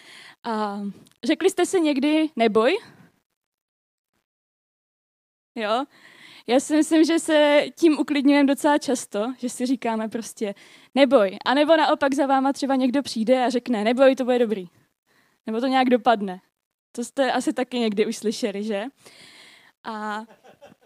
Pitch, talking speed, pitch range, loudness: 255 Hz, 140 wpm, 225-290 Hz, -22 LUFS